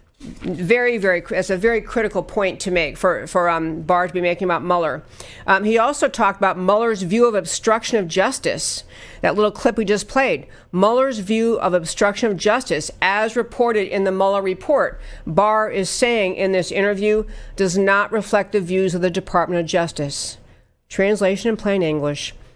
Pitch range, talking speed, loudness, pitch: 180-215 Hz, 180 wpm, -19 LUFS, 195 Hz